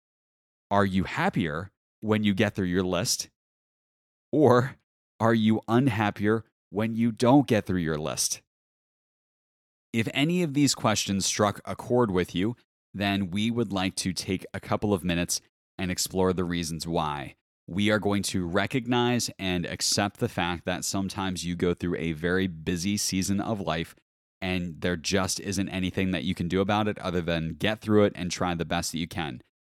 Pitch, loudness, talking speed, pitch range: 95 Hz, -27 LUFS, 180 wpm, 90-110 Hz